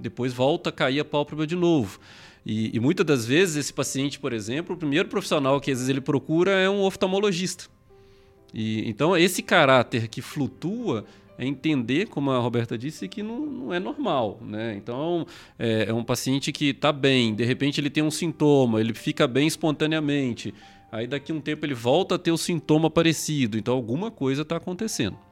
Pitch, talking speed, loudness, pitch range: 145 Hz, 195 wpm, -24 LUFS, 120-165 Hz